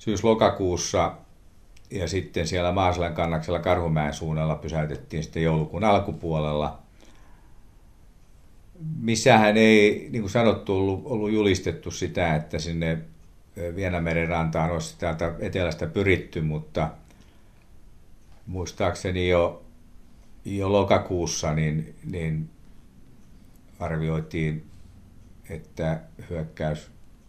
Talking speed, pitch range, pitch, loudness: 85 wpm, 80-100 Hz, 85 Hz, -25 LUFS